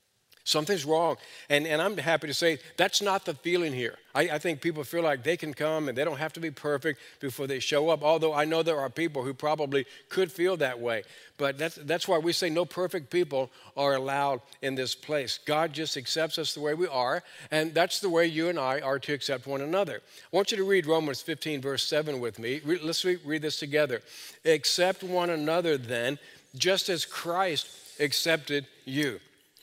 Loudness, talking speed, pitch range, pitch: -29 LUFS, 210 wpm, 140-170 Hz, 155 Hz